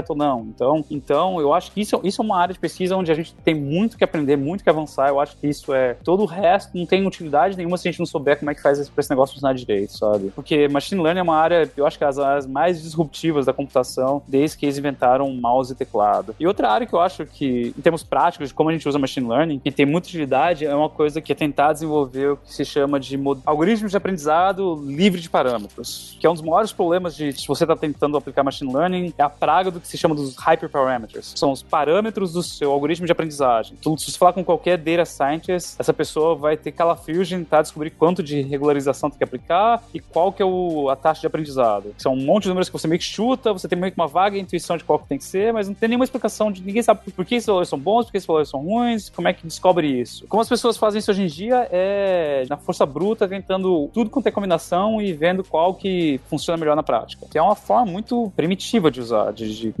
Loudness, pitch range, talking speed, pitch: -20 LUFS, 145-185 Hz, 265 wpm, 160 Hz